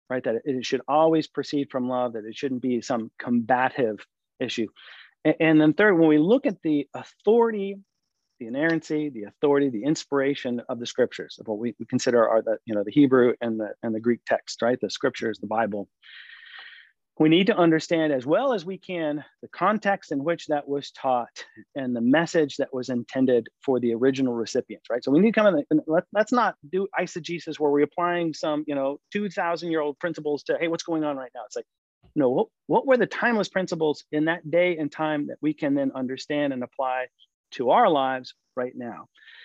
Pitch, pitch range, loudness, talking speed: 145 Hz, 125-170 Hz, -24 LUFS, 210 wpm